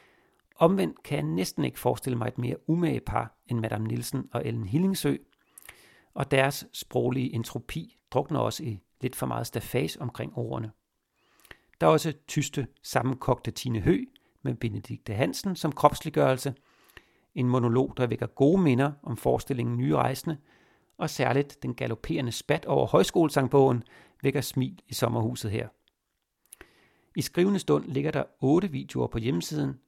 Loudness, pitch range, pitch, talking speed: -28 LUFS, 120-155 Hz, 135 Hz, 145 wpm